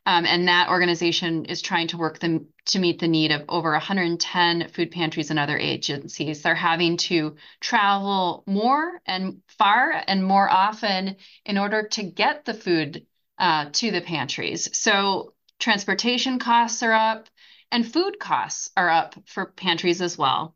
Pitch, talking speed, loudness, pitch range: 175 Hz, 160 wpm, -22 LUFS, 165-205 Hz